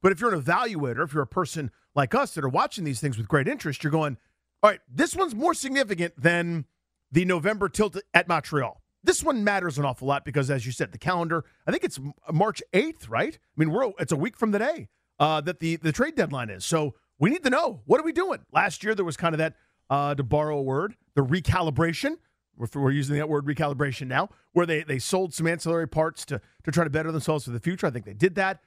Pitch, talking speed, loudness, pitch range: 160 Hz, 245 wpm, -26 LUFS, 145-185 Hz